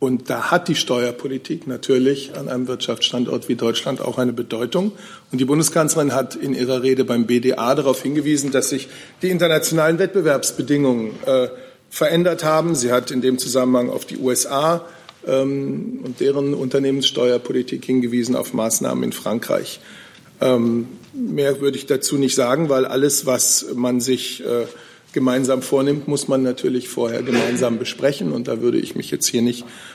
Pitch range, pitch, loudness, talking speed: 125-145 Hz, 130 Hz, -19 LUFS, 160 wpm